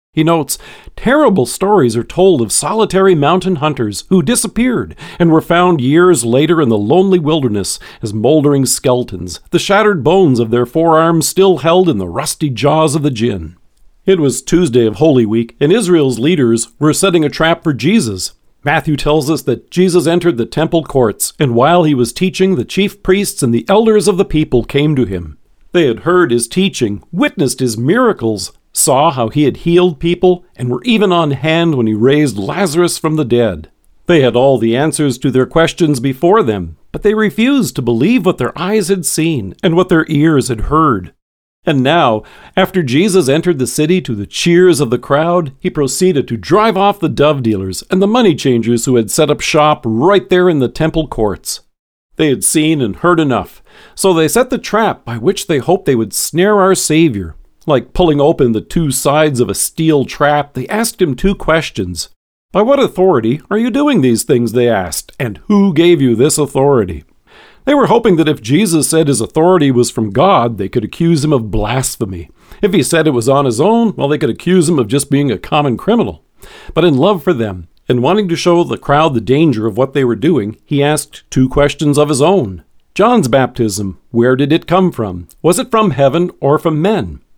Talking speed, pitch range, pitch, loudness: 205 wpm, 120-180 Hz, 155 Hz, -12 LUFS